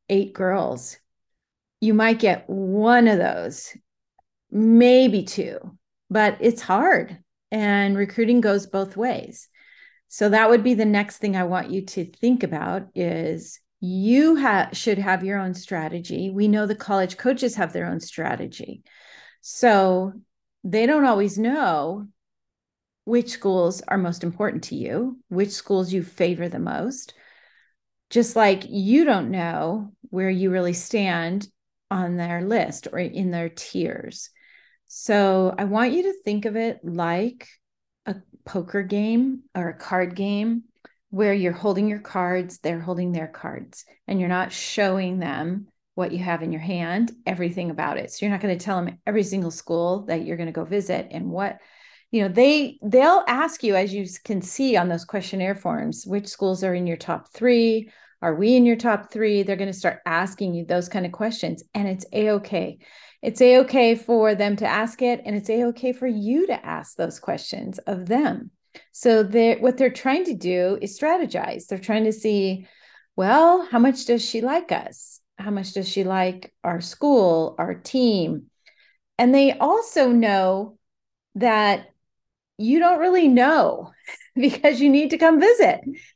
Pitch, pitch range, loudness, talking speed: 205 Hz, 185-235 Hz, -21 LUFS, 170 wpm